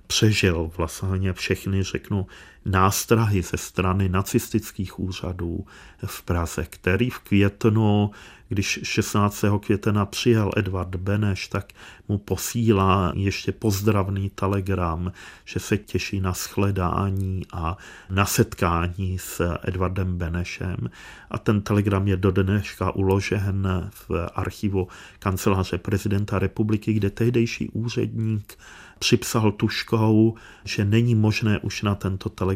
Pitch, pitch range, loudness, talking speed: 100 Hz, 95-105 Hz, -24 LUFS, 110 wpm